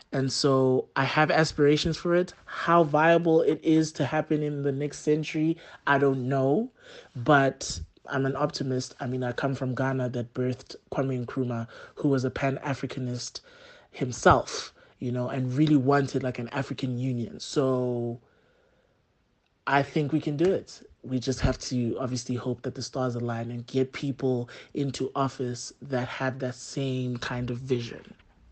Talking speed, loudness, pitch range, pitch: 165 wpm, -27 LUFS, 125-145 Hz, 135 Hz